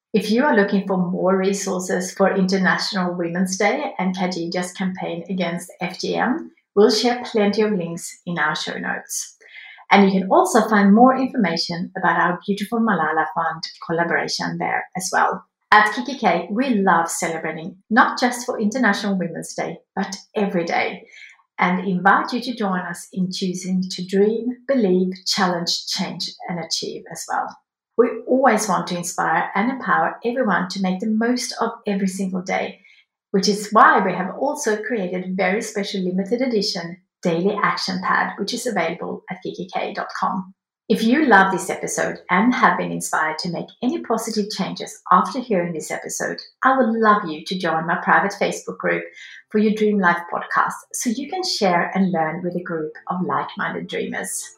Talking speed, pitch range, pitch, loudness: 165 wpm, 180-225 Hz, 195 Hz, -20 LUFS